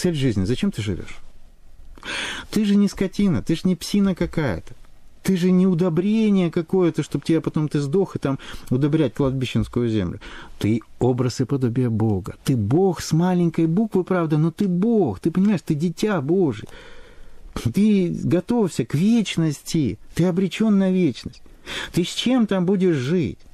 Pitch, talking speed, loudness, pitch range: 170 Hz, 160 wpm, -21 LUFS, 130-190 Hz